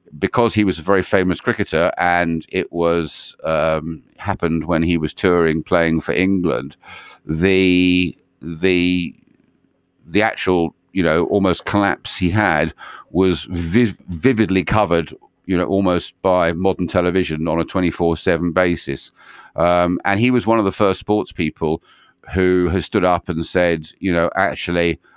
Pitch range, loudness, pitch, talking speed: 85-95 Hz, -18 LUFS, 90 Hz, 150 wpm